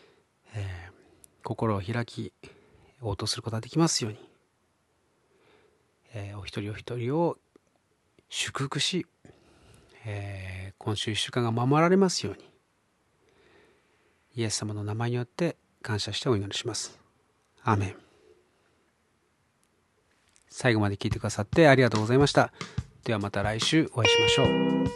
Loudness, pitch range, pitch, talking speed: -27 LUFS, 105-130 Hz, 115 Hz, 260 characters per minute